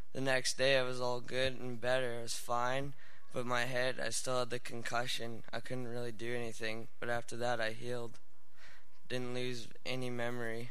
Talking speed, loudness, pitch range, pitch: 185 wpm, -38 LUFS, 120-125 Hz, 125 Hz